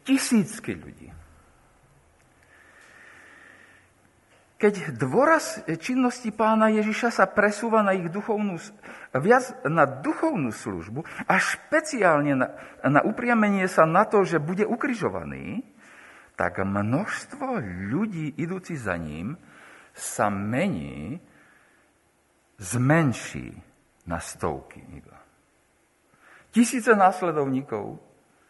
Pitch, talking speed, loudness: 185 Hz, 85 wpm, -24 LUFS